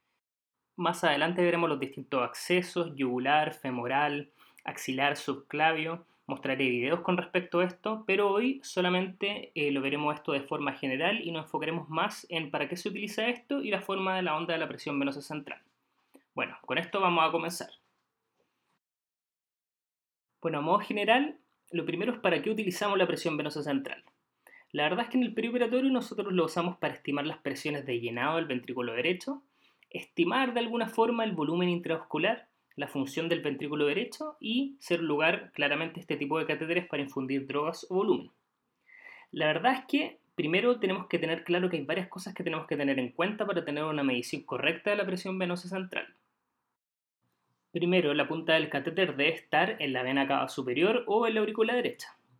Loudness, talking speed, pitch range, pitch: -30 LUFS, 180 wpm, 150-200 Hz, 170 Hz